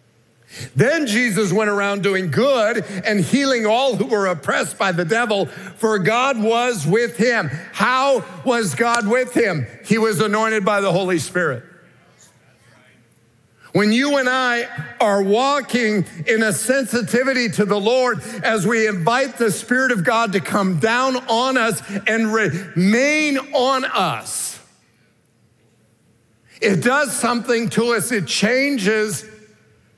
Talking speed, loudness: 135 wpm, -18 LUFS